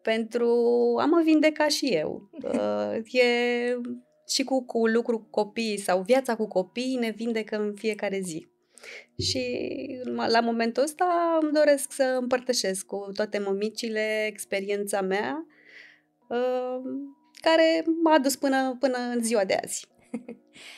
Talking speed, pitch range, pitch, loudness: 125 wpm, 210-270 Hz, 240 Hz, -26 LUFS